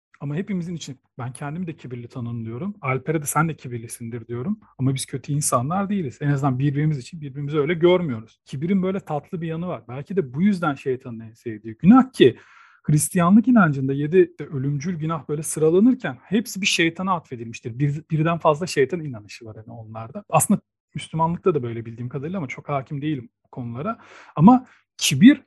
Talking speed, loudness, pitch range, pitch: 175 wpm, -22 LUFS, 130-185 Hz, 150 Hz